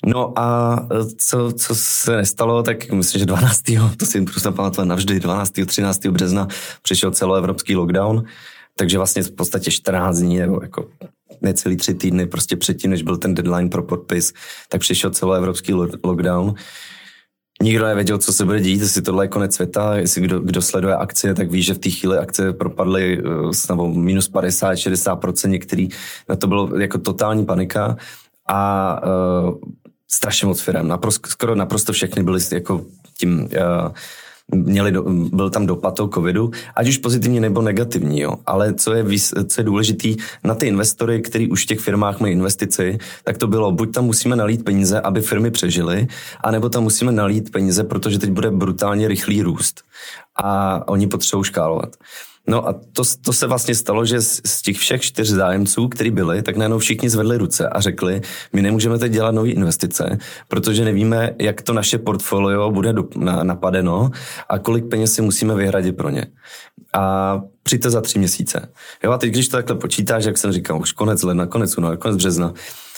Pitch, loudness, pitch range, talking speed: 100 Hz, -18 LUFS, 95-110 Hz, 180 wpm